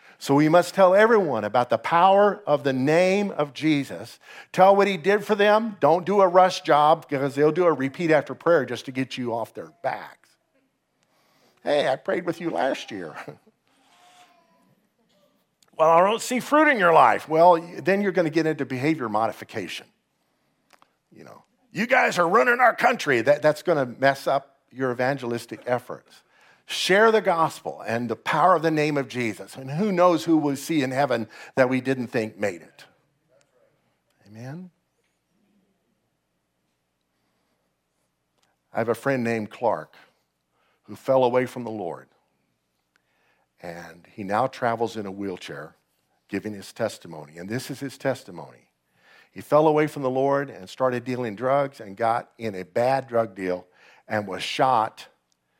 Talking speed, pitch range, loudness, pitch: 165 wpm, 110-165 Hz, -22 LUFS, 135 Hz